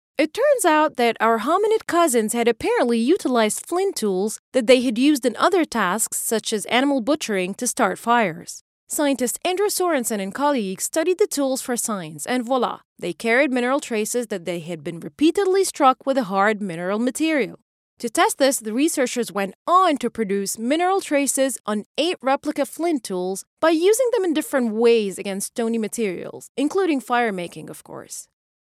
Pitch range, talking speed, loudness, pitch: 215-305 Hz, 175 wpm, -21 LUFS, 250 Hz